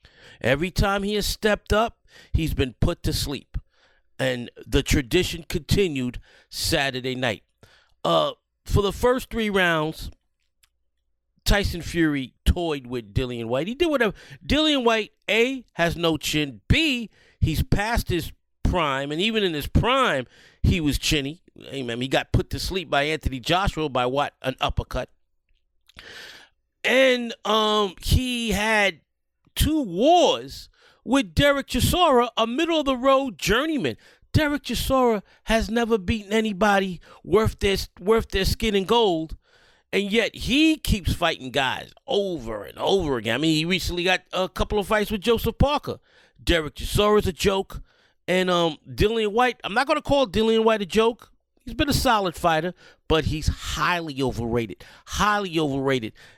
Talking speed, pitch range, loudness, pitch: 155 wpm, 150-230 Hz, -23 LUFS, 195 Hz